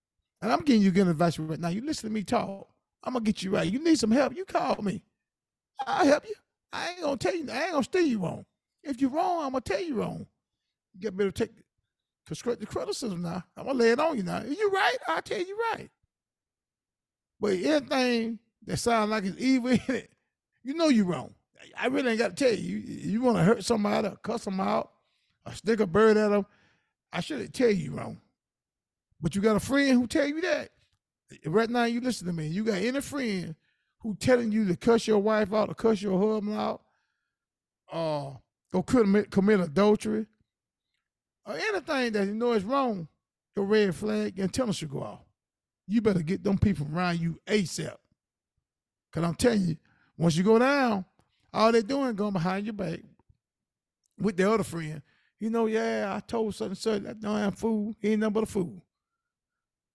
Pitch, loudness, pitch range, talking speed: 215 Hz, -28 LUFS, 195-250 Hz, 205 wpm